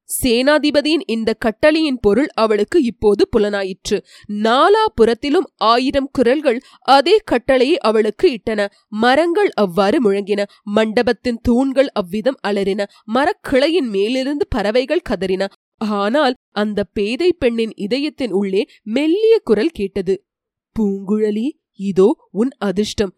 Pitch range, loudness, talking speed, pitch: 205-280 Hz, -17 LUFS, 100 wpm, 235 Hz